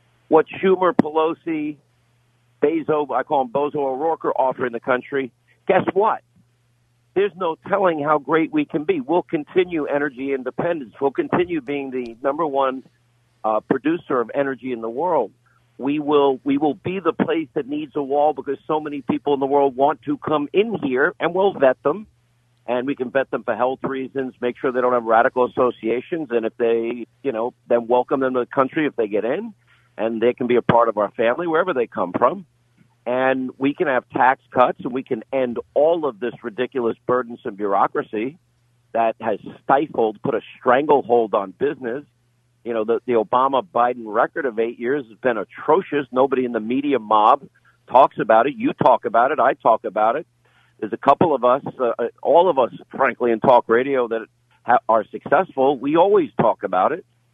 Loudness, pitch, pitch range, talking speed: -20 LUFS, 130 Hz, 120-150 Hz, 195 wpm